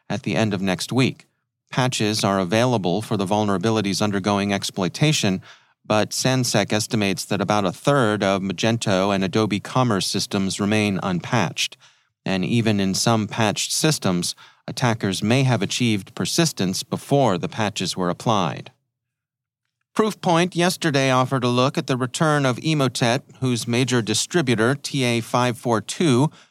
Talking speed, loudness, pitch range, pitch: 135 wpm, -21 LUFS, 105-130 Hz, 120 Hz